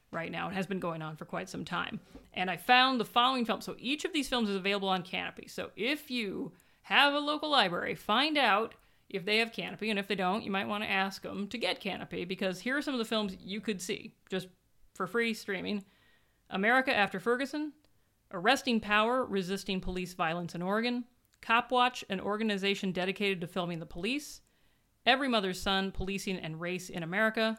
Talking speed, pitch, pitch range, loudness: 200 wpm, 205 Hz, 190-240 Hz, -31 LUFS